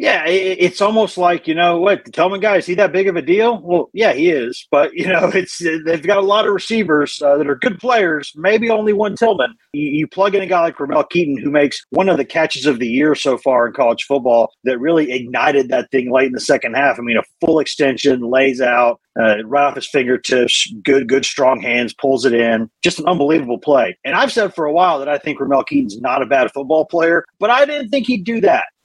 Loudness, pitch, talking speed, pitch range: -15 LUFS, 155 Hz, 250 wpm, 135-195 Hz